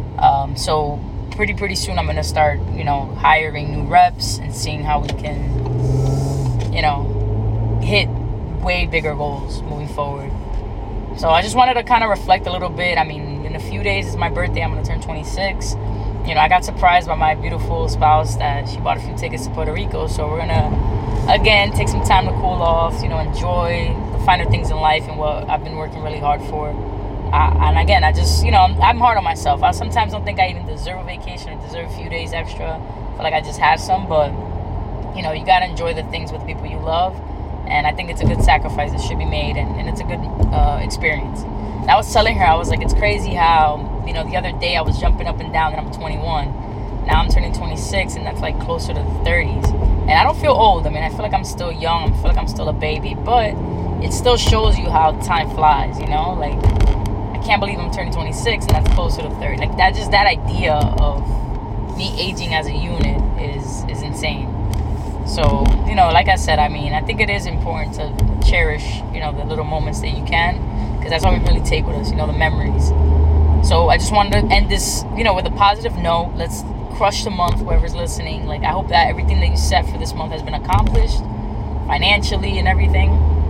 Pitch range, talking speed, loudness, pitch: 80-120 Hz, 230 wpm, -18 LUFS, 100 Hz